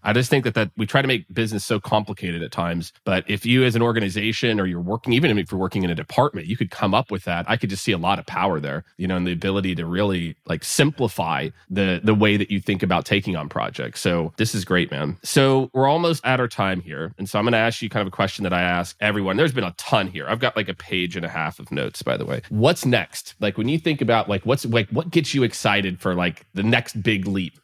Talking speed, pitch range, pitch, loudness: 280 wpm, 95-120 Hz, 105 Hz, -22 LUFS